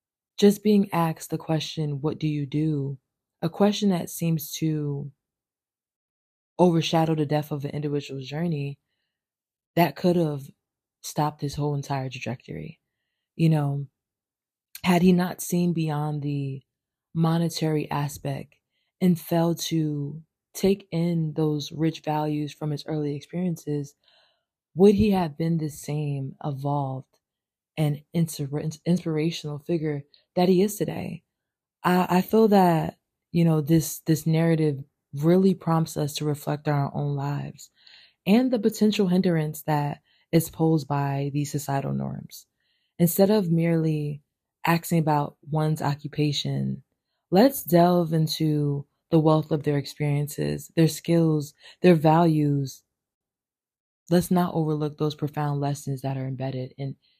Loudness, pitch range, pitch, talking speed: -25 LUFS, 145-170 Hz, 155 Hz, 130 wpm